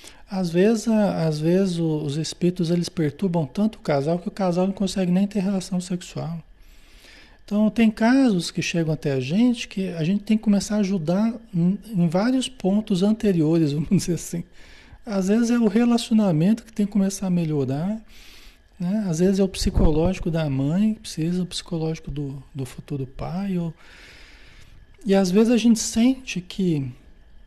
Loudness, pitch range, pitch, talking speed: -22 LUFS, 165-210 Hz, 185 Hz, 170 wpm